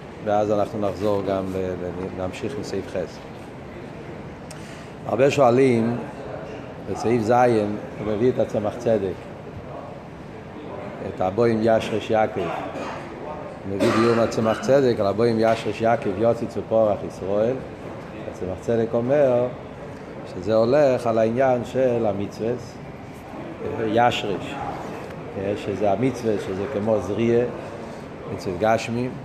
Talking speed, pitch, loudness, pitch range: 100 wpm, 115 Hz, -22 LUFS, 105-120 Hz